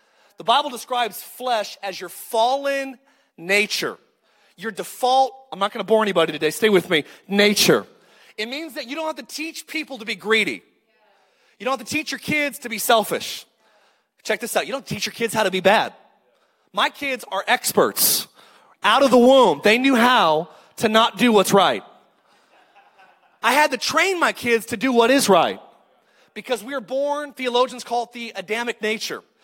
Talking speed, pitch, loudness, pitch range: 190 wpm, 235 Hz, -20 LUFS, 210-270 Hz